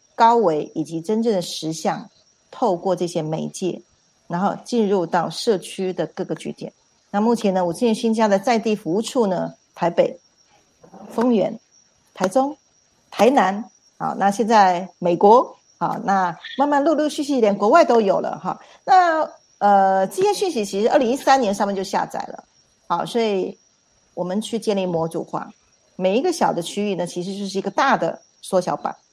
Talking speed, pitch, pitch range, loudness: 250 characters per minute, 200 Hz, 180-235 Hz, -20 LUFS